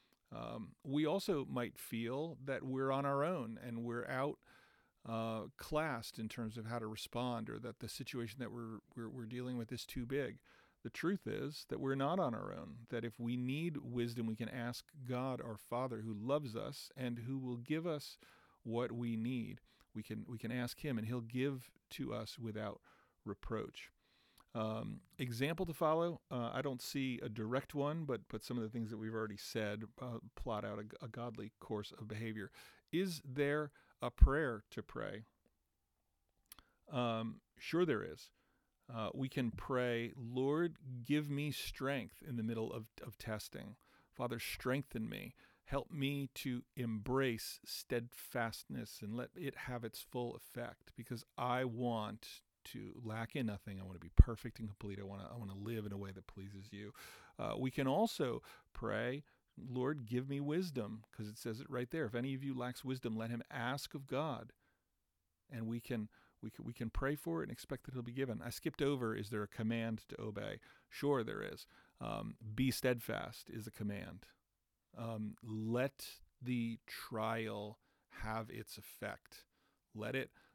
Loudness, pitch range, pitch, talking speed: -42 LUFS, 110-135 Hz, 120 Hz, 180 wpm